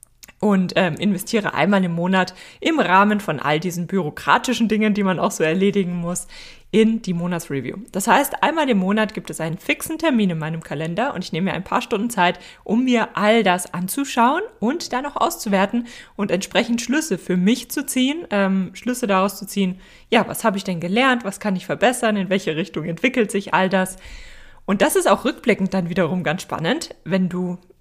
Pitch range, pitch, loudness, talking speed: 180-230 Hz, 195 Hz, -20 LUFS, 200 wpm